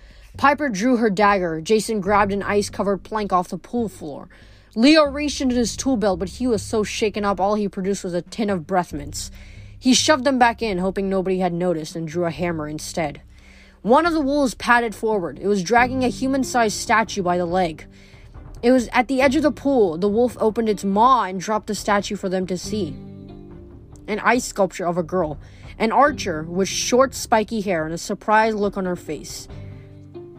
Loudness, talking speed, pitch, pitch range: -20 LUFS, 205 wpm, 200 Hz, 175-230 Hz